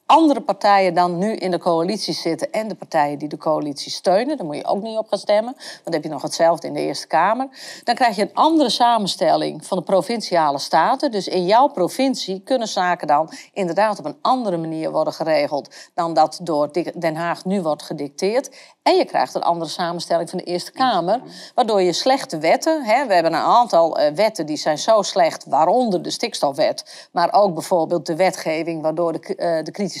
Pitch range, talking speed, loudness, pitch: 165-235 Hz, 205 wpm, -19 LUFS, 185 Hz